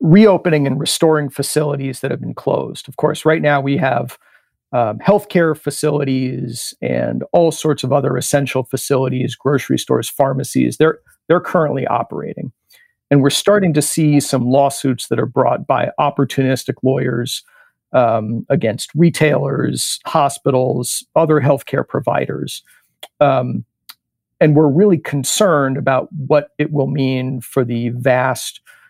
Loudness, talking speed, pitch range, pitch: -16 LUFS, 135 wpm, 130-155 Hz, 140 Hz